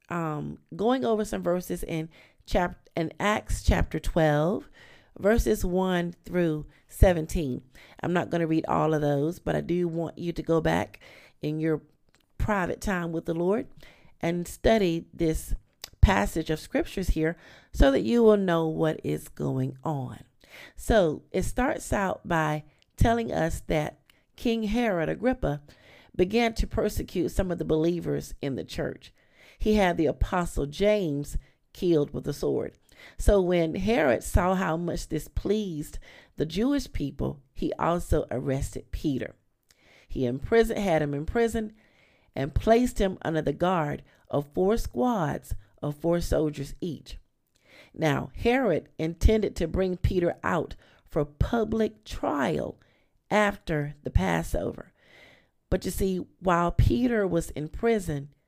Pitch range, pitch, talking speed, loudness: 150-200 Hz, 165 Hz, 145 wpm, -27 LUFS